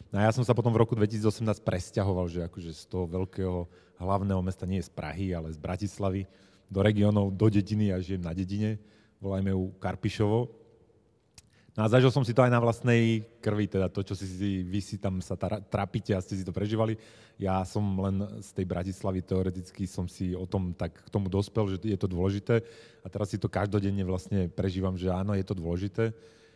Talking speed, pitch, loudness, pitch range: 205 wpm, 100 Hz, -30 LUFS, 95-110 Hz